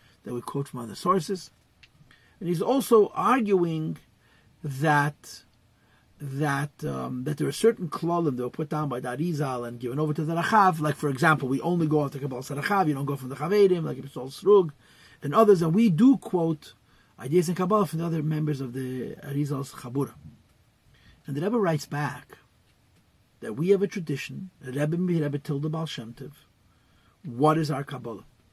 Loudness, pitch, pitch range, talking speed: -26 LUFS, 150 Hz, 130-170 Hz, 185 wpm